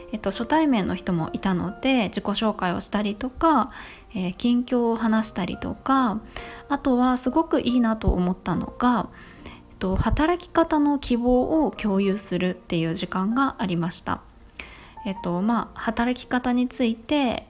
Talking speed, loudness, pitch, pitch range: 300 characters per minute, -24 LUFS, 235 Hz, 195-255 Hz